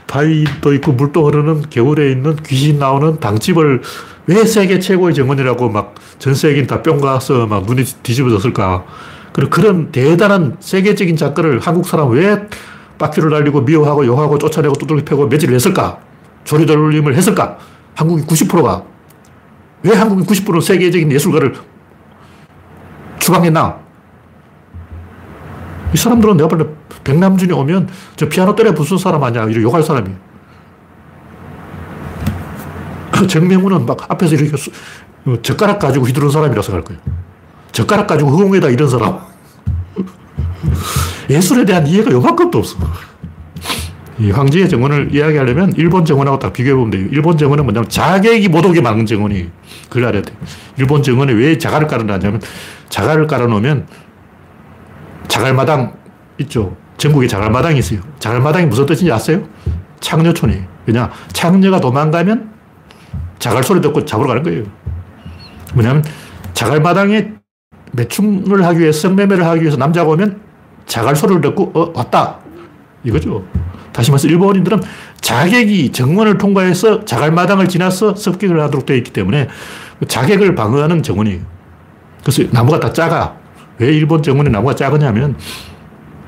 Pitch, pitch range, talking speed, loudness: 145 Hz, 110-170 Hz, 330 characters per minute, -12 LUFS